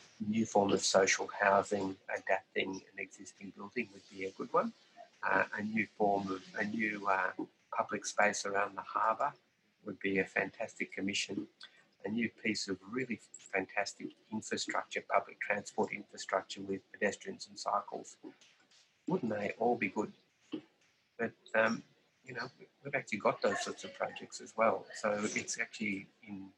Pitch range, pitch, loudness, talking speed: 95-110 Hz, 100 Hz, -36 LUFS, 155 wpm